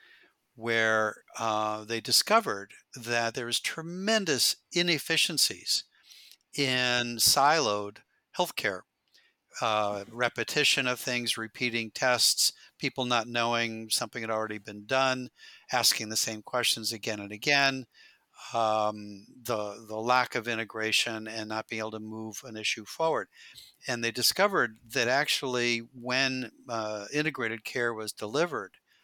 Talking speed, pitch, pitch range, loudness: 125 wpm, 115 Hz, 110-125 Hz, -28 LUFS